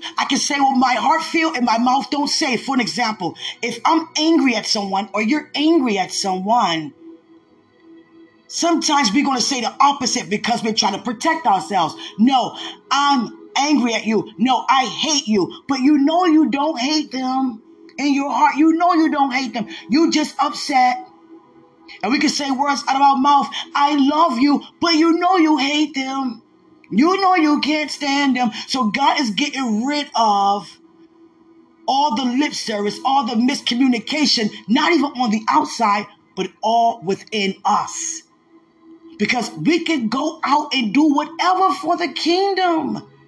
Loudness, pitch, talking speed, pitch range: -18 LUFS, 280 Hz, 170 wpm, 240-320 Hz